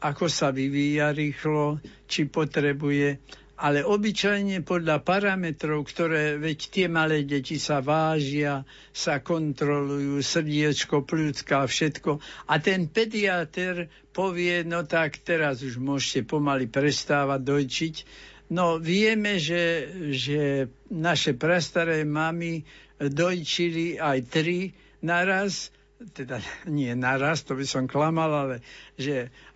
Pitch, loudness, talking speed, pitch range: 155 Hz, -26 LUFS, 110 wpm, 140-170 Hz